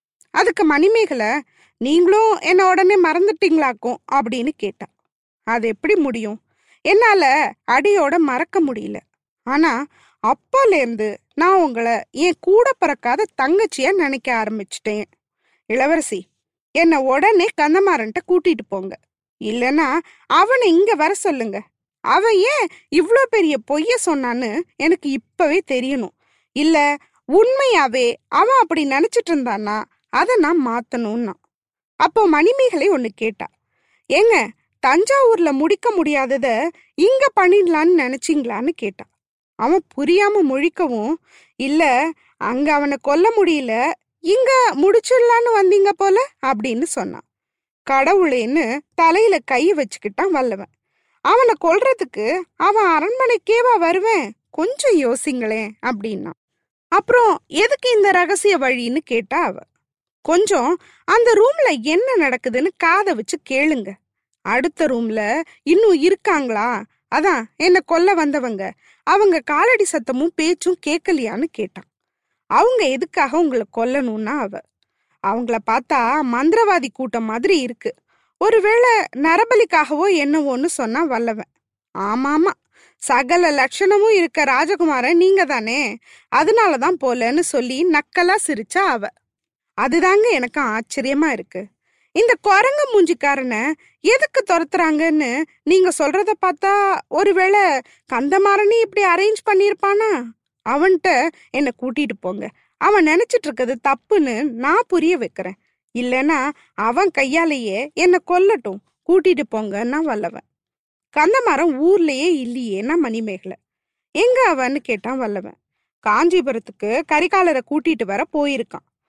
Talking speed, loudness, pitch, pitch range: 100 wpm, -17 LUFS, 325 Hz, 260-390 Hz